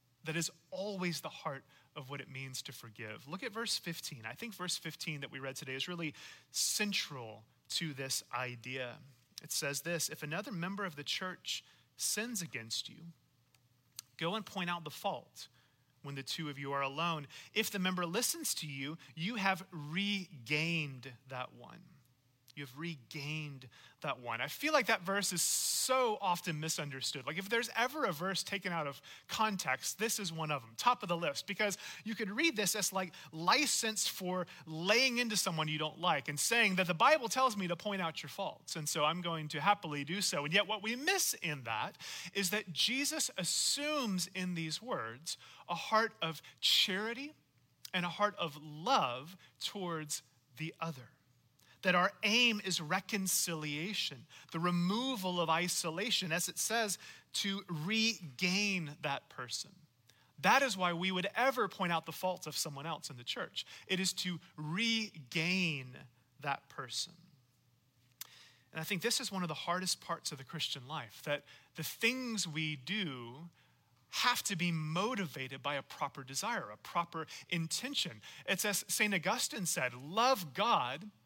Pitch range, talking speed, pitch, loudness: 145-200 Hz, 170 wpm, 170 Hz, -35 LUFS